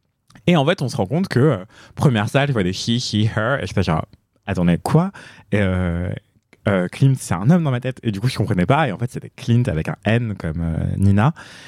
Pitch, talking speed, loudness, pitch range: 115 Hz, 260 wpm, -20 LUFS, 100-135 Hz